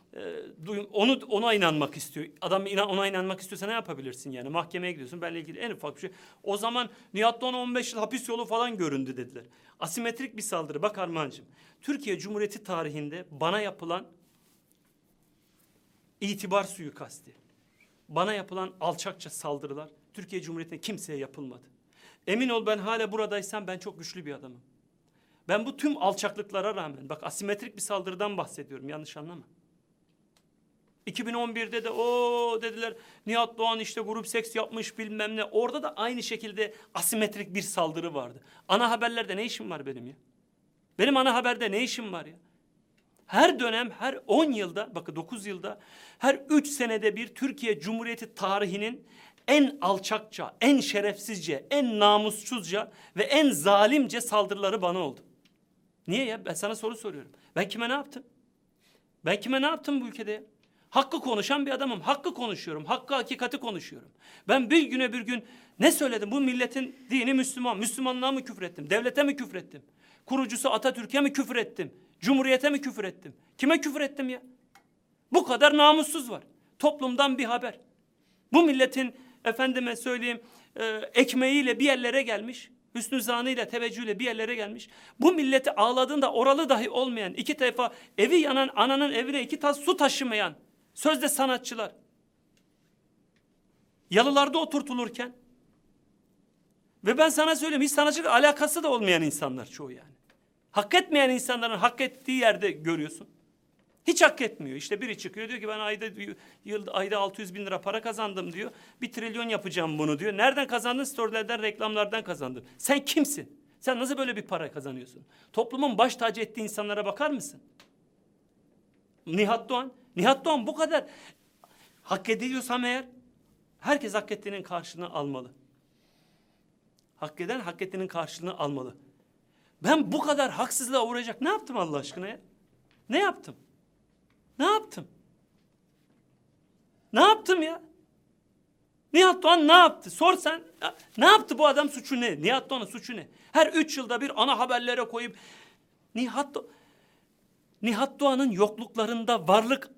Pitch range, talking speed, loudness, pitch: 195-265 Hz, 145 wpm, -27 LUFS, 230 Hz